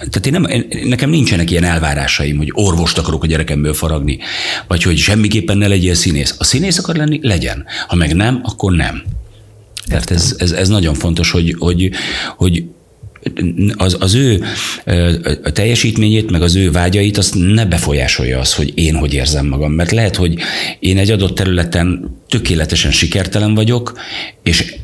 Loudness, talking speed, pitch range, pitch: -13 LUFS, 165 wpm, 80-105 Hz, 90 Hz